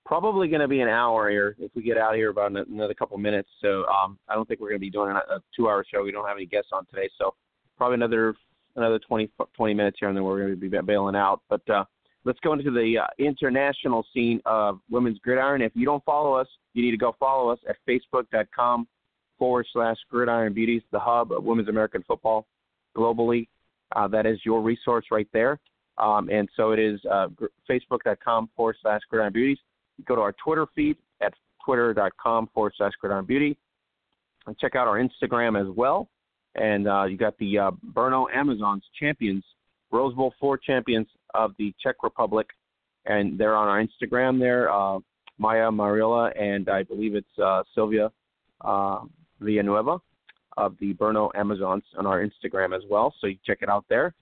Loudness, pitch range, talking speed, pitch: -25 LUFS, 105-120 Hz, 195 wpm, 110 Hz